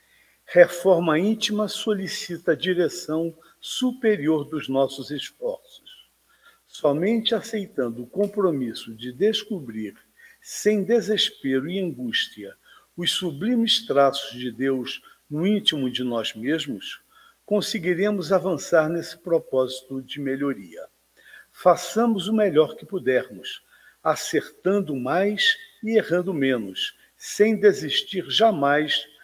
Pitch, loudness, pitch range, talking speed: 180 Hz, -23 LUFS, 140-215 Hz, 100 wpm